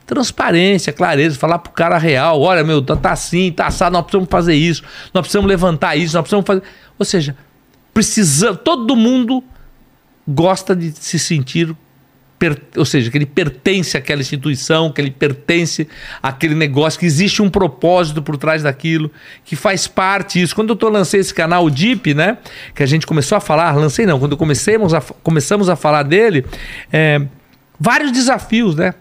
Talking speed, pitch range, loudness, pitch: 170 wpm, 150-195 Hz, -14 LUFS, 170 Hz